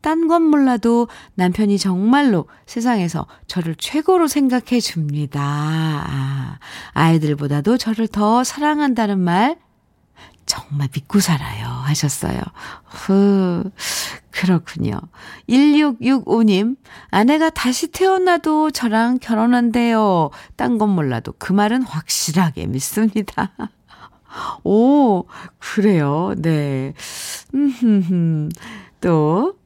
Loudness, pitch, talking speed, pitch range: -18 LUFS, 205 Hz, 200 characters per minute, 160-250 Hz